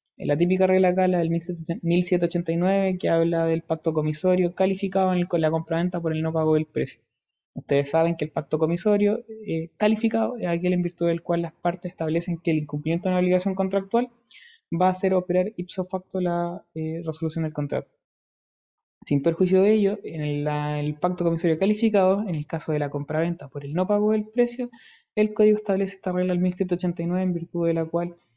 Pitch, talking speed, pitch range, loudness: 175 Hz, 190 wpm, 165-190 Hz, -24 LUFS